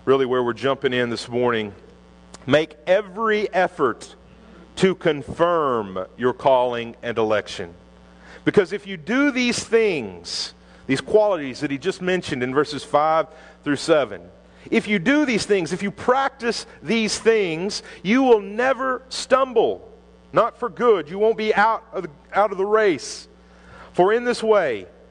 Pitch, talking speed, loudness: 185 Hz, 150 wpm, -21 LUFS